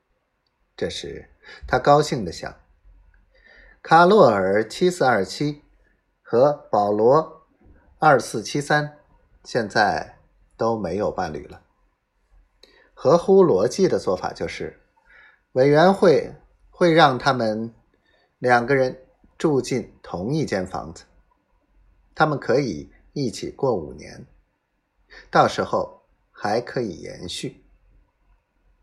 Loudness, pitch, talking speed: -20 LUFS, 150 Hz, 150 characters per minute